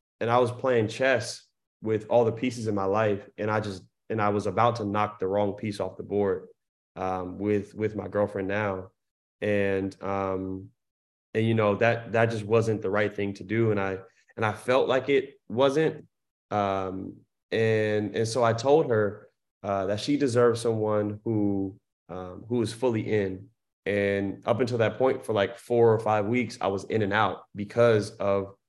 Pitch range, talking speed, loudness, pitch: 100-115 Hz, 190 wpm, -27 LUFS, 105 Hz